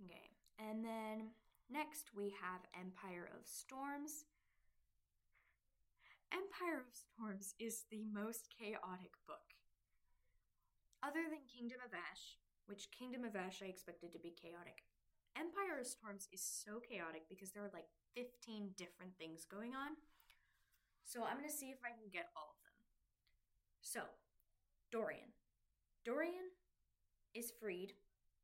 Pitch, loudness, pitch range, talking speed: 220 Hz, -50 LUFS, 190-255 Hz, 135 wpm